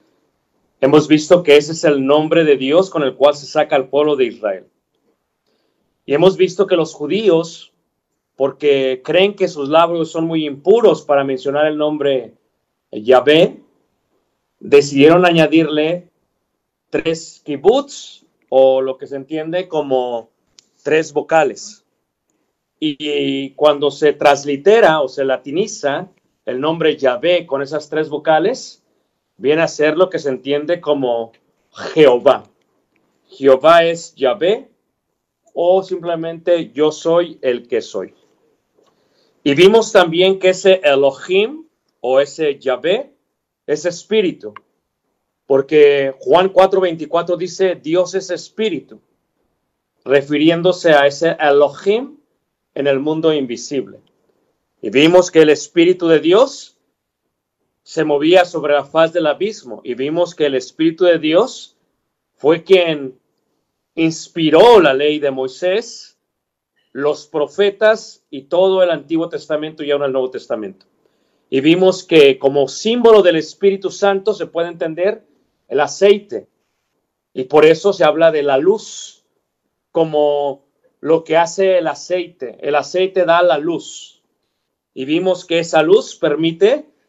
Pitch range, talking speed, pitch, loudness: 145-185 Hz, 130 wpm, 160 Hz, -15 LUFS